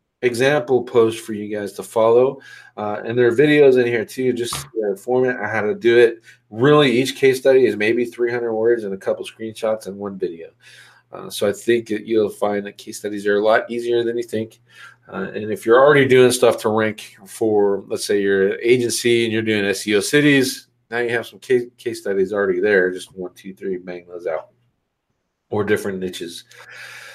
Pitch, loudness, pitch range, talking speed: 115 Hz, -18 LUFS, 105-125 Hz, 210 wpm